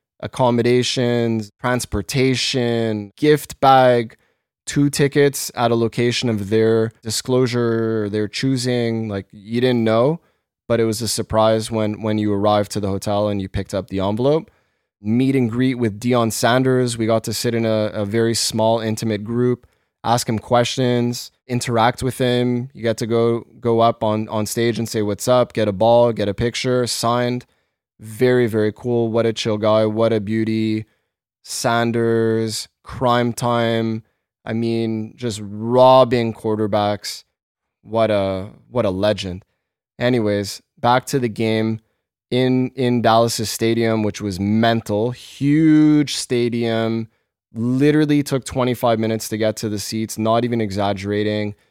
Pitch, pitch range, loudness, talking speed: 115 Hz, 110-120 Hz, -19 LUFS, 150 wpm